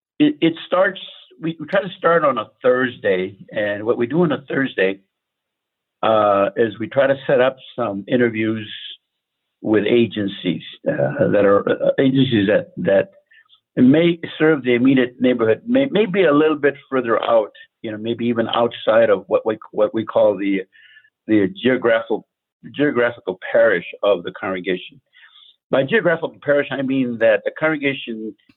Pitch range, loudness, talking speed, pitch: 110-155 Hz, -18 LUFS, 155 wpm, 125 Hz